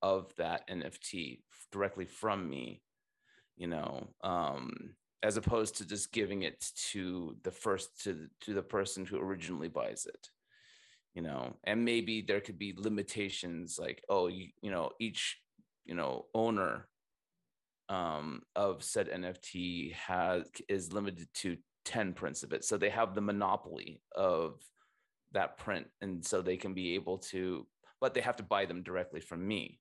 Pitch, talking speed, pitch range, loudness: 95 Hz, 160 wpm, 90-110 Hz, -37 LUFS